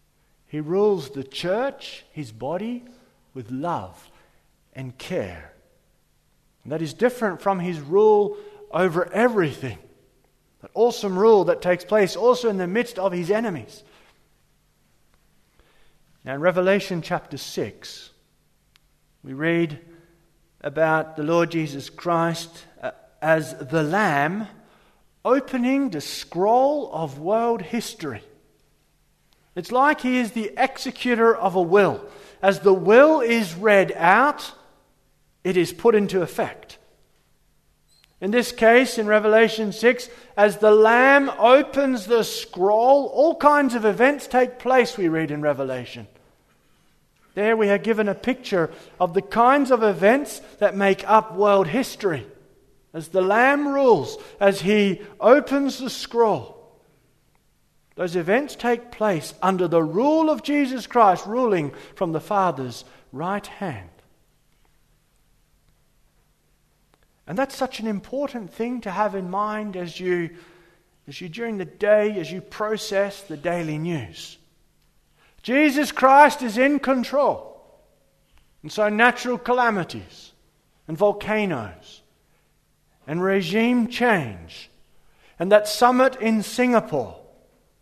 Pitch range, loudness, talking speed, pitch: 170-240 Hz, -21 LUFS, 120 wpm, 205 Hz